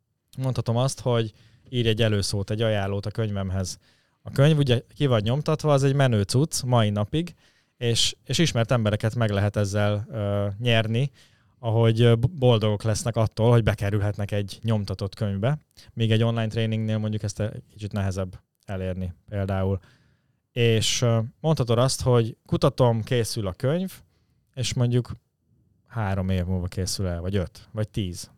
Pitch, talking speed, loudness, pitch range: 115 Hz, 150 wpm, -24 LUFS, 105-125 Hz